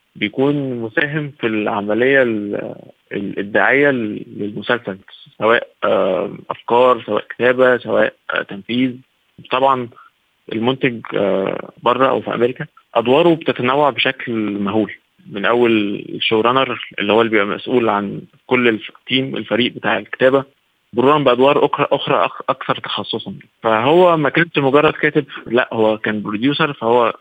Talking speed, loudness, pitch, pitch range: 115 wpm, -17 LUFS, 125 Hz, 110-140 Hz